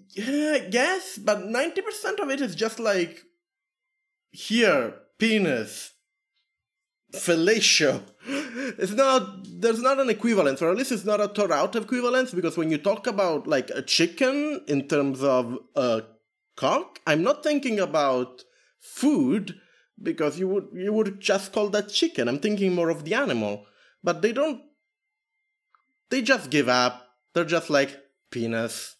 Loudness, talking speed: -24 LUFS, 150 wpm